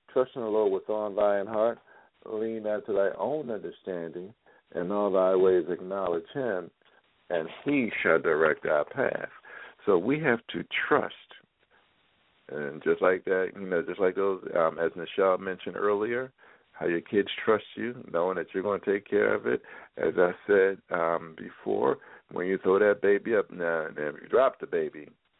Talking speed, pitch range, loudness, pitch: 185 wpm, 95-130 Hz, -28 LUFS, 100 Hz